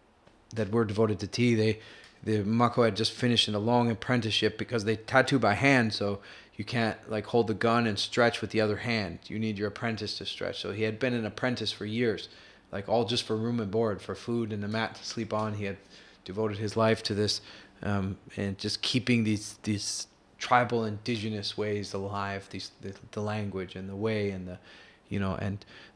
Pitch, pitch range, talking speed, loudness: 110 Hz, 100-115 Hz, 210 wpm, -29 LUFS